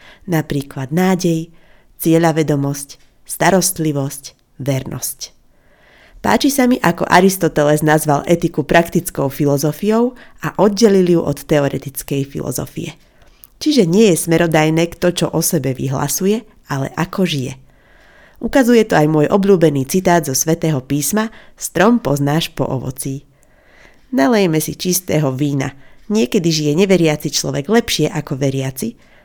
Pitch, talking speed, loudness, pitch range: 160 Hz, 115 wpm, -16 LUFS, 140-185 Hz